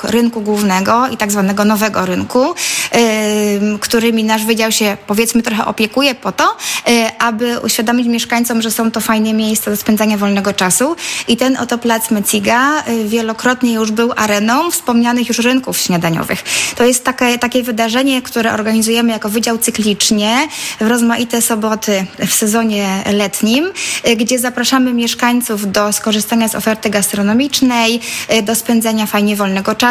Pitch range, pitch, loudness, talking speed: 215-240 Hz, 230 Hz, -13 LUFS, 140 wpm